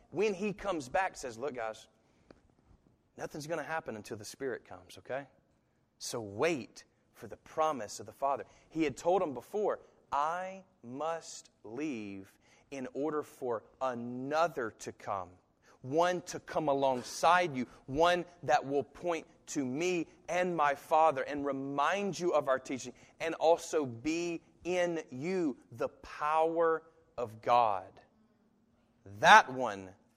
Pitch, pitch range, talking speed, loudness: 155 Hz, 130-170 Hz, 135 wpm, -33 LUFS